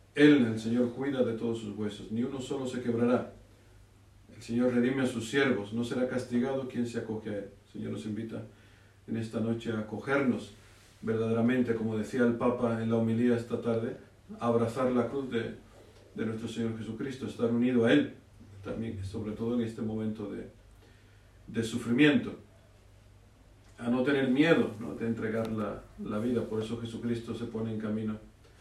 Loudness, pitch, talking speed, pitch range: -31 LUFS, 115 Hz, 180 wpm, 105-120 Hz